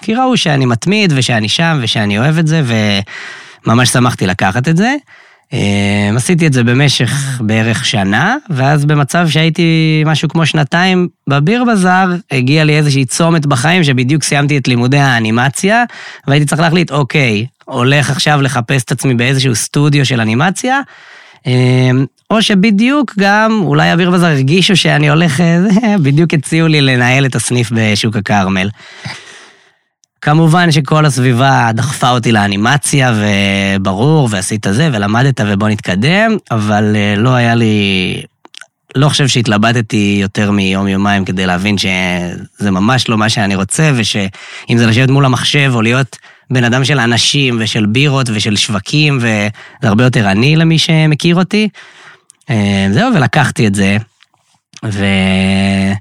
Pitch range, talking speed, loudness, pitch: 110-155 Hz, 135 wpm, -11 LUFS, 130 Hz